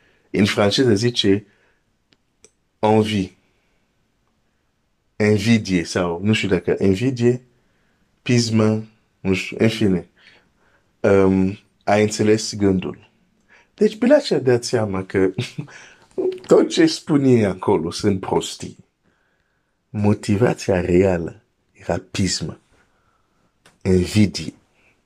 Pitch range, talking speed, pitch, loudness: 95-120 Hz, 90 wpm, 105 Hz, -19 LUFS